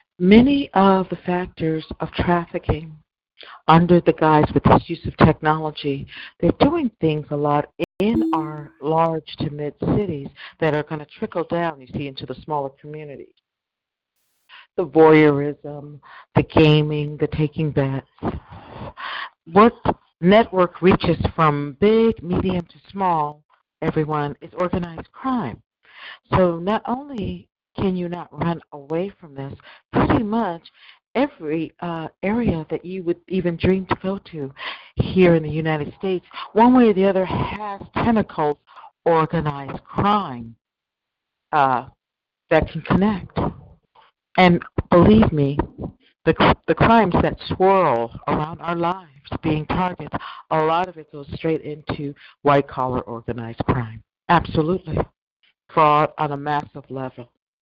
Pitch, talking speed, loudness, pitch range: 160 Hz, 130 wpm, -20 LUFS, 145-180 Hz